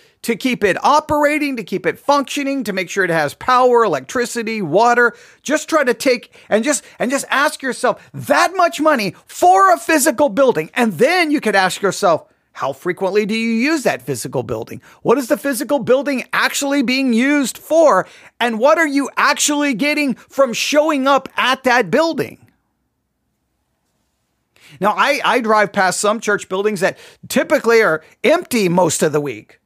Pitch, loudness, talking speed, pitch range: 255 Hz, -16 LUFS, 170 wpm, 215-290 Hz